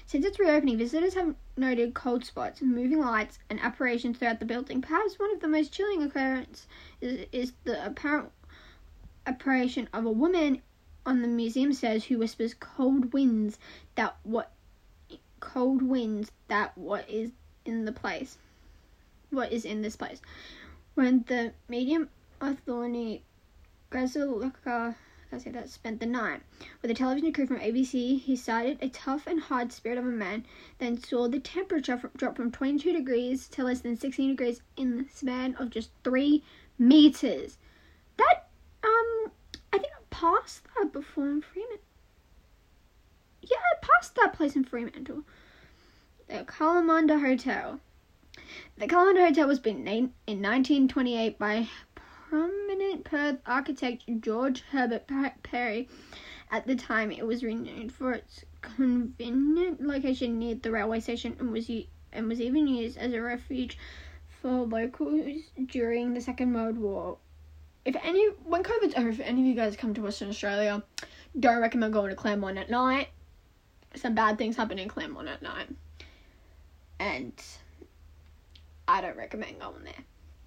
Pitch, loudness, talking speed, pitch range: 250 Hz, -29 LUFS, 150 wpm, 225-285 Hz